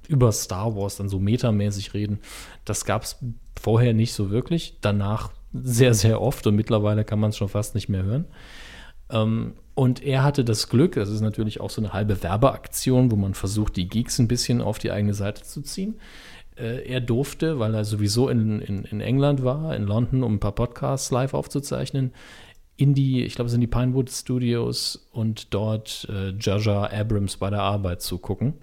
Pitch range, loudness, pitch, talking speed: 105-125 Hz, -24 LUFS, 110 Hz, 190 wpm